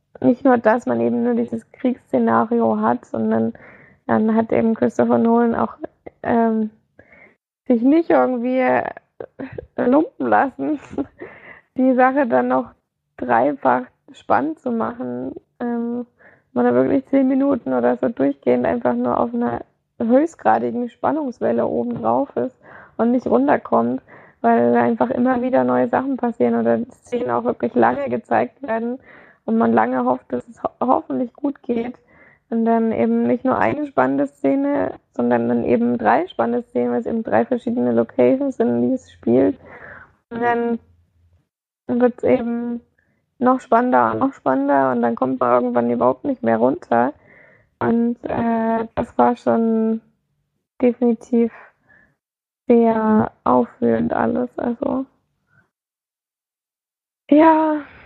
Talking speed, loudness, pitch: 135 wpm, -19 LUFS, 225 Hz